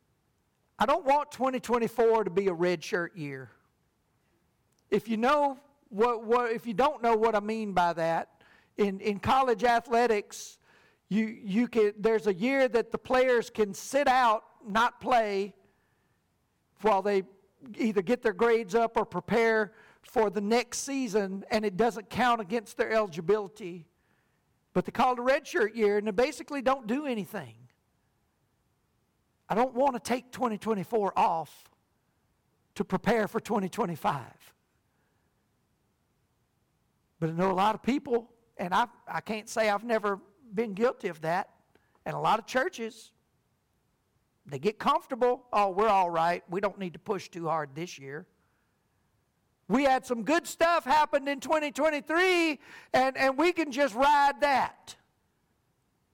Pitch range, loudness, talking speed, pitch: 200-255 Hz, -28 LUFS, 150 wpm, 225 Hz